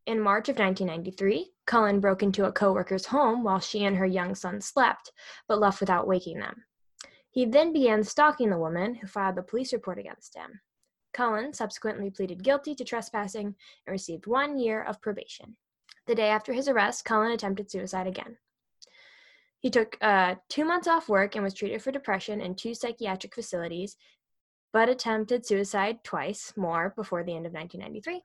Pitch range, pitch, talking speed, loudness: 190-240 Hz, 210 Hz, 175 wpm, -28 LUFS